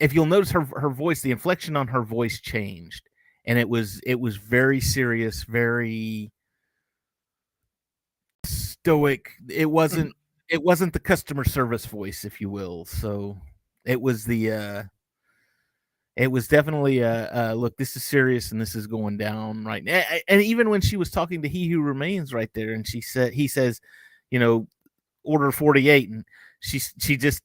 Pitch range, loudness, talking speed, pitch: 110-150 Hz, -23 LUFS, 170 wpm, 125 Hz